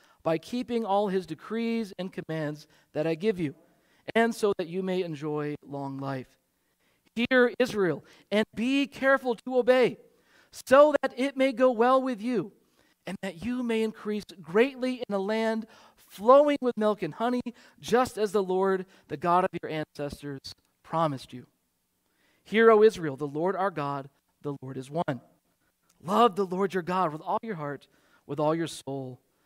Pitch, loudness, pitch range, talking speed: 195 Hz, -27 LUFS, 155-230 Hz, 170 wpm